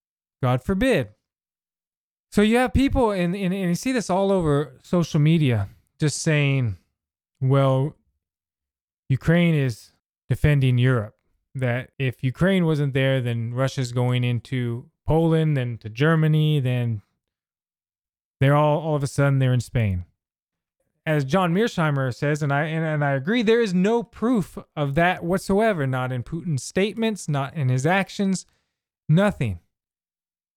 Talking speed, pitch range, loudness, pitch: 145 wpm, 120-170 Hz, -22 LUFS, 140 Hz